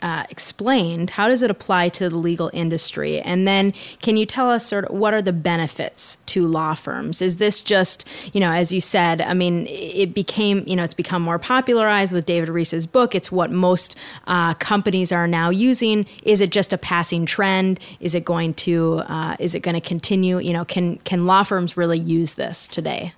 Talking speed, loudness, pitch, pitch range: 210 wpm, -19 LUFS, 180 Hz, 170-200 Hz